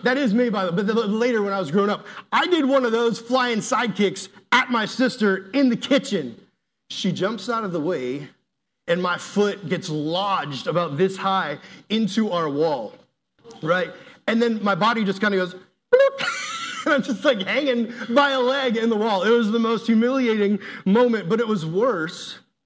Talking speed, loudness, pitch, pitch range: 195 wpm, -22 LUFS, 220 Hz, 190-245 Hz